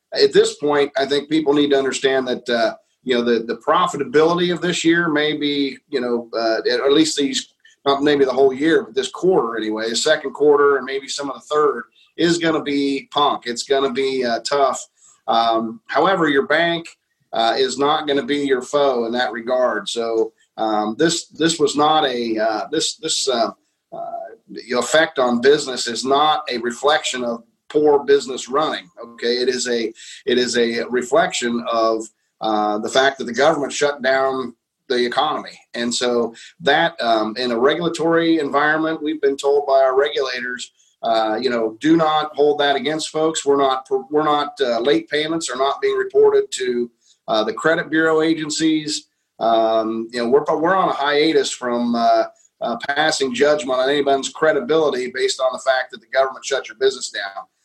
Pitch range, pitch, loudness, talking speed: 120-155 Hz, 140 Hz, -19 LUFS, 185 wpm